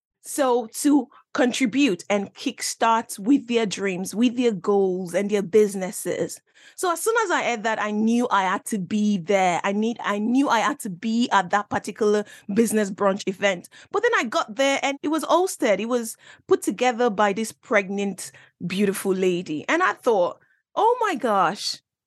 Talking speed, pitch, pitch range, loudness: 180 wpm, 220 Hz, 200-265 Hz, -23 LUFS